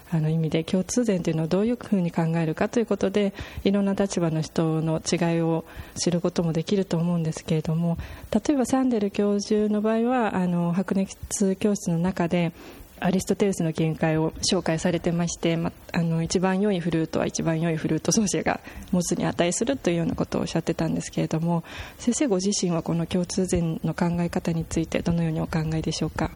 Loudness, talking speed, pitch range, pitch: -25 LUFS, 420 characters per minute, 165-200 Hz, 175 Hz